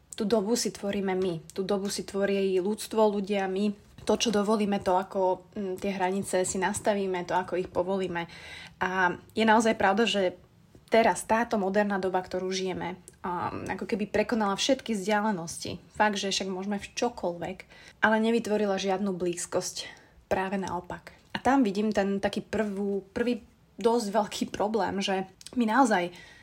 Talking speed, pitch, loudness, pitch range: 150 wpm, 200 Hz, -28 LUFS, 185-215 Hz